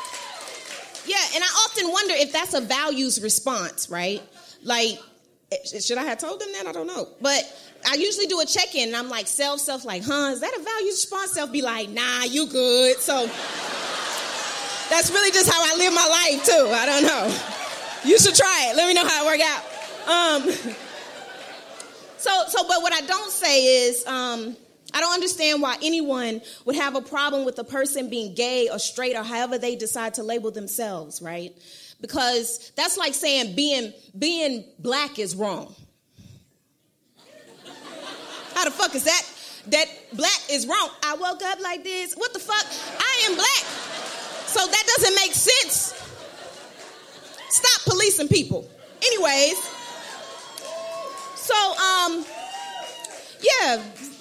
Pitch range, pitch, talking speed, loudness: 245-360 Hz, 295 Hz, 160 wpm, -21 LUFS